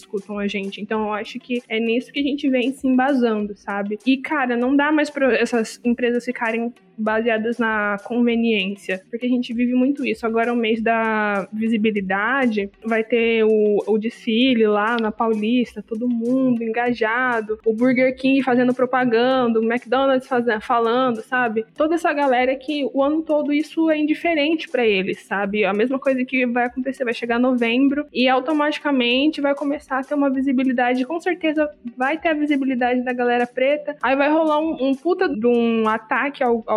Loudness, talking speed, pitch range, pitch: -20 LUFS, 180 wpm, 225-270 Hz, 245 Hz